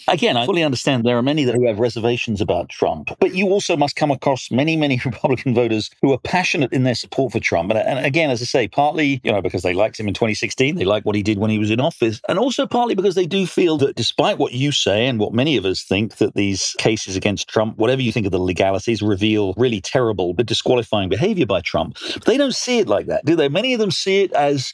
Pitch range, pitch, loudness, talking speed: 110-145 Hz, 120 Hz, -18 LUFS, 260 wpm